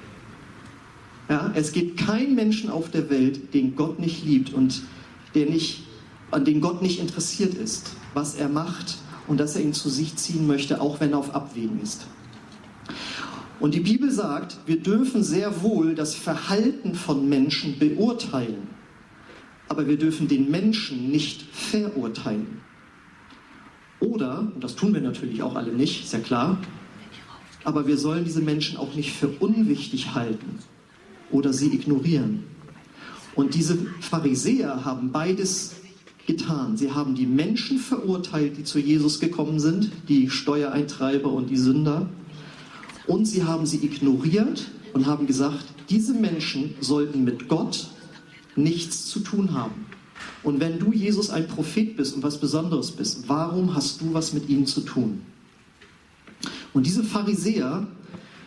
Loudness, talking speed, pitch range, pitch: -24 LUFS, 145 wpm, 145-190 Hz, 155 Hz